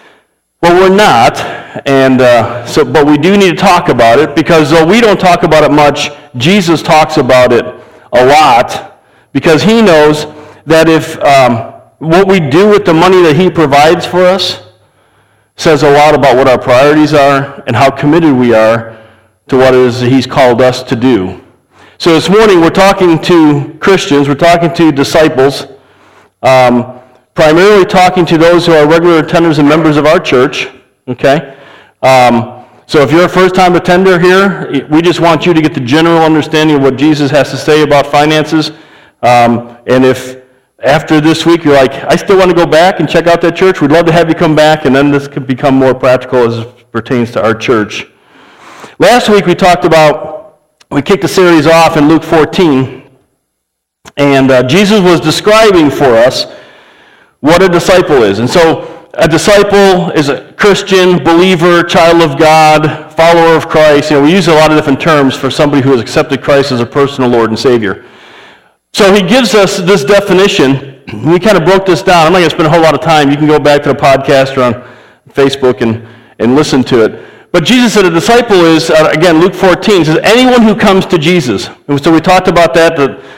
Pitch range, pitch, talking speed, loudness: 135-175 Hz, 155 Hz, 200 wpm, -6 LUFS